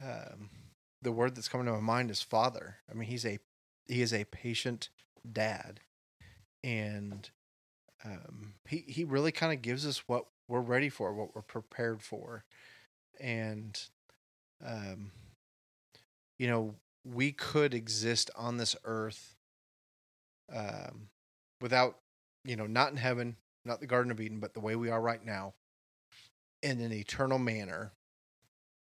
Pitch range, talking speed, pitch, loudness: 100-125 Hz, 145 wpm, 115 Hz, -35 LUFS